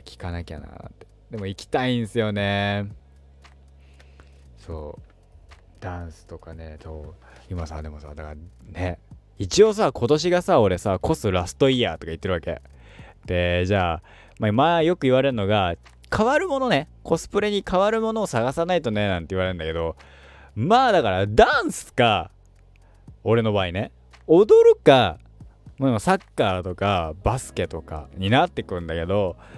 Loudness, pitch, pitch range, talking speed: -21 LUFS, 95 Hz, 80-115 Hz, 310 characters per minute